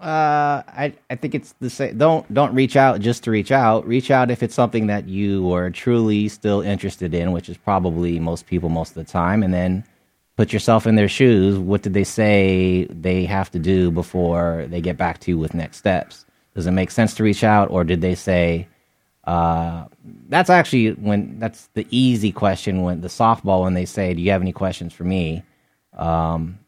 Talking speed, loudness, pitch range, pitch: 210 wpm, -19 LUFS, 90-110 Hz, 95 Hz